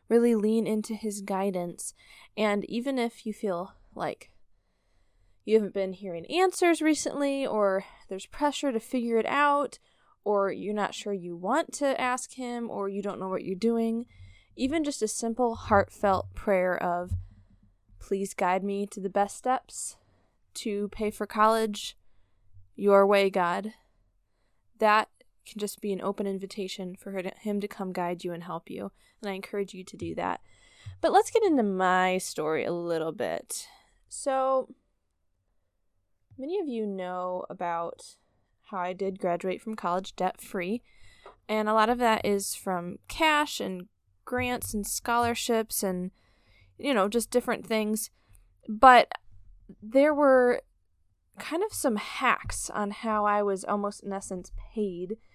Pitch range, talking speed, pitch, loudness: 180-230 Hz, 155 wpm, 200 Hz, -28 LUFS